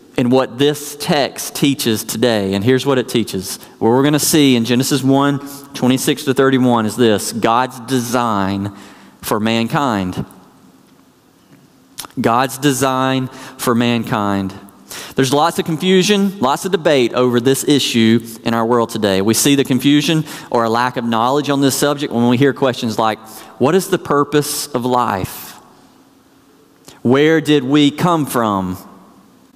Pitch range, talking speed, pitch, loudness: 115-145 Hz, 150 wpm, 130 Hz, -15 LUFS